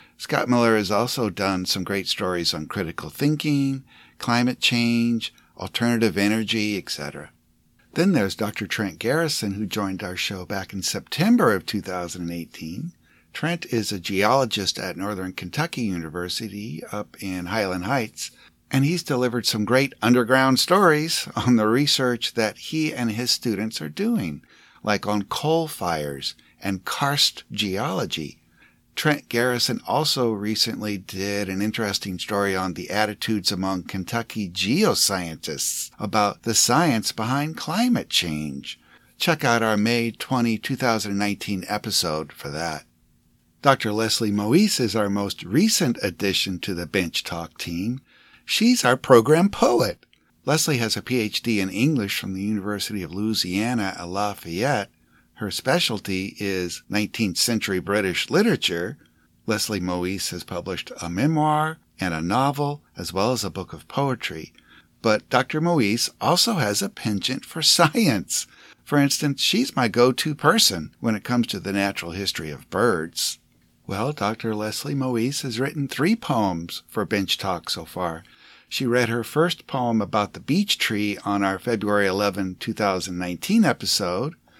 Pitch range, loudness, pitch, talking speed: 95-130 Hz, -23 LUFS, 110 Hz, 145 wpm